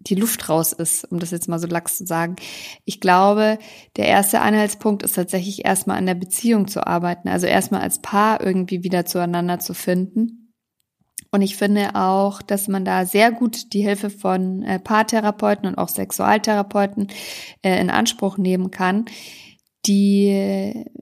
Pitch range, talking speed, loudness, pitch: 185-210 Hz, 155 wpm, -19 LUFS, 195 Hz